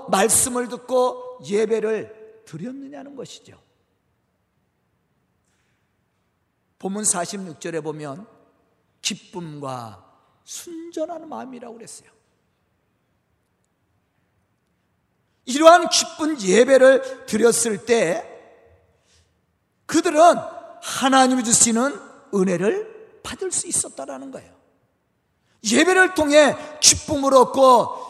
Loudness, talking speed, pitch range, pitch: -18 LUFS, 175 characters per minute, 215-310 Hz, 250 Hz